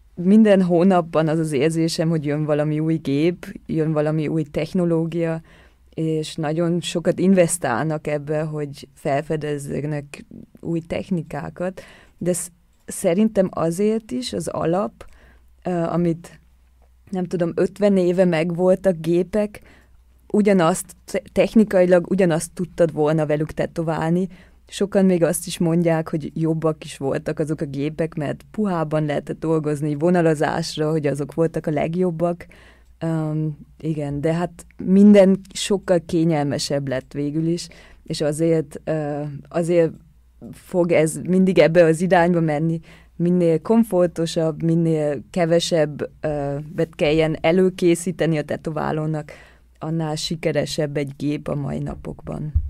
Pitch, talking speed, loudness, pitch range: 165 Hz, 120 wpm, -21 LUFS, 150-175 Hz